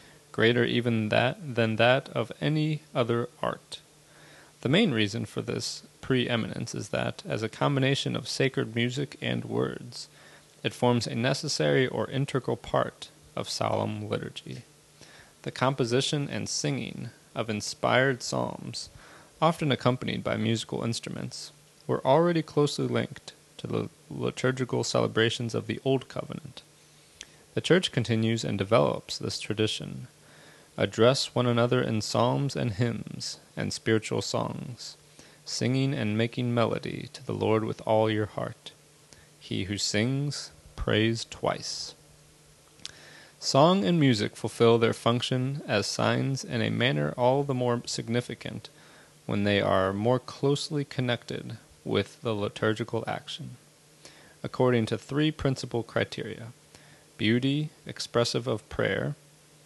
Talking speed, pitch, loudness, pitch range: 125 wpm, 120 Hz, -28 LUFS, 110-140 Hz